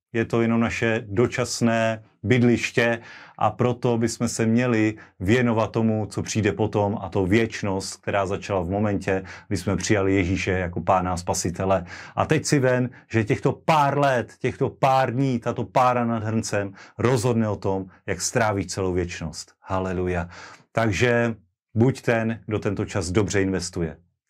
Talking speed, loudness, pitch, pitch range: 155 wpm, -23 LUFS, 110 Hz, 95-120 Hz